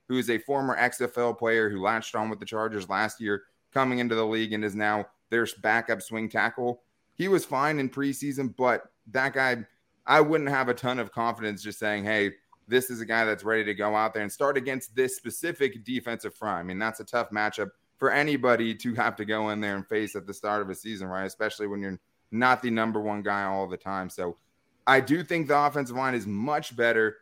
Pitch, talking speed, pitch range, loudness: 115 Hz, 230 wpm, 105-125 Hz, -27 LUFS